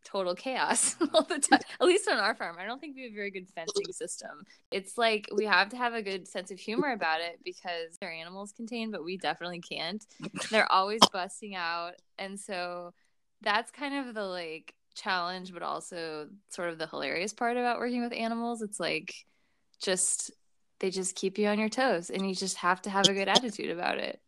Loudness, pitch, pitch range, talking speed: -30 LUFS, 195 Hz, 180-235 Hz, 210 wpm